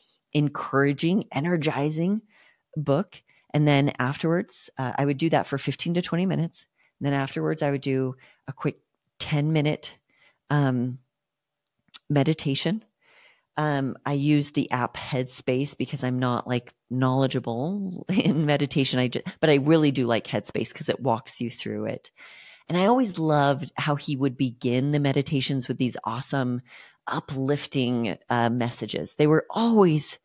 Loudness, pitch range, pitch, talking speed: -25 LUFS, 130-155 Hz, 140 Hz, 145 wpm